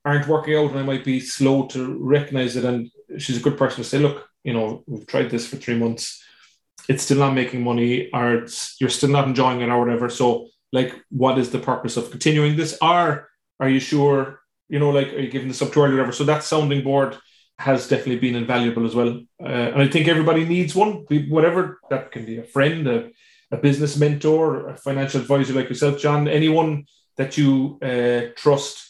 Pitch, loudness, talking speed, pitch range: 135 Hz, -20 LUFS, 215 wpm, 125-150 Hz